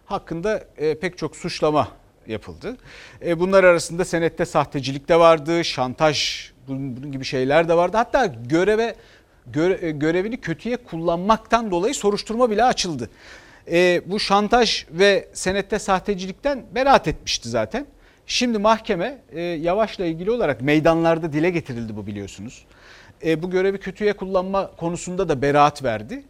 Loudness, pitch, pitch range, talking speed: -21 LUFS, 170 Hz, 150-200 Hz, 120 wpm